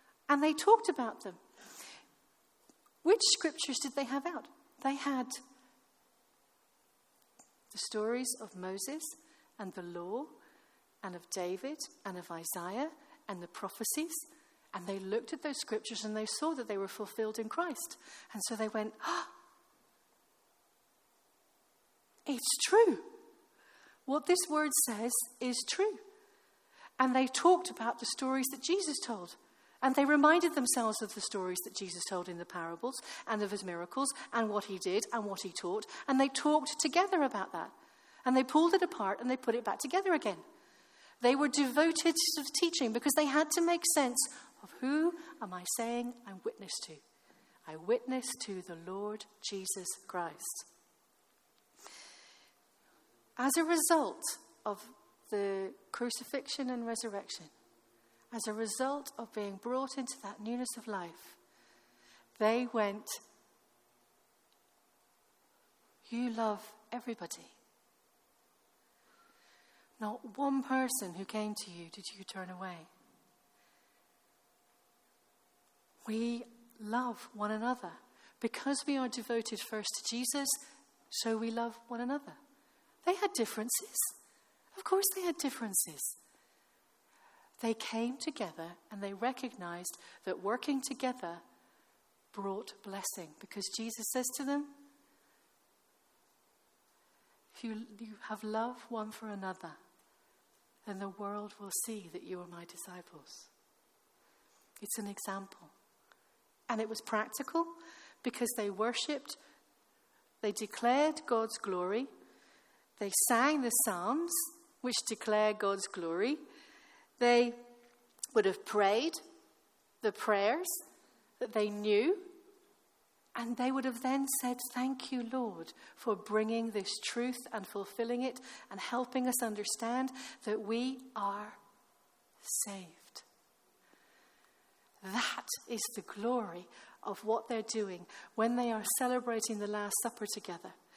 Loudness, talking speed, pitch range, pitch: -35 LUFS, 130 wpm, 210-280 Hz, 235 Hz